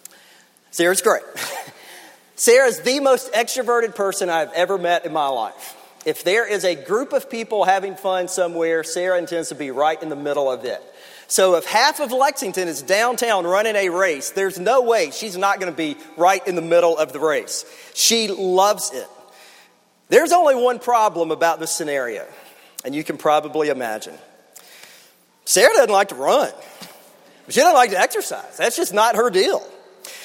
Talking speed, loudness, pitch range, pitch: 175 wpm, -19 LUFS, 170-240 Hz, 195 Hz